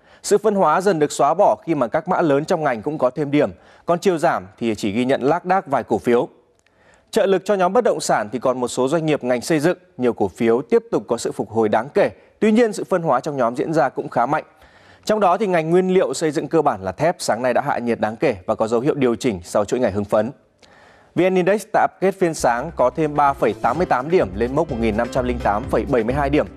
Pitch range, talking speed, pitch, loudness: 120-180 Hz, 255 wpm, 145 Hz, -19 LUFS